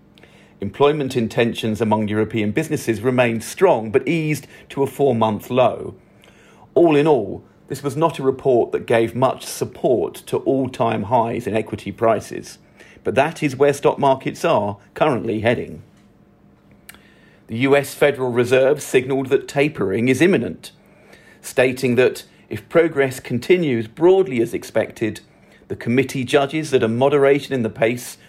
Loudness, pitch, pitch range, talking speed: -19 LUFS, 130 Hz, 115-145 Hz, 145 wpm